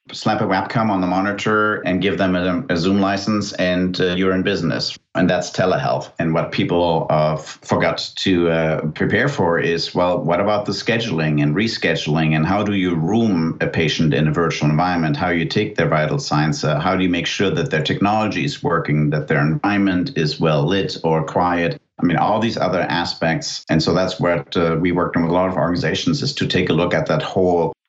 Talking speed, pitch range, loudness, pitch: 220 wpm, 80-100 Hz, -18 LUFS, 90 Hz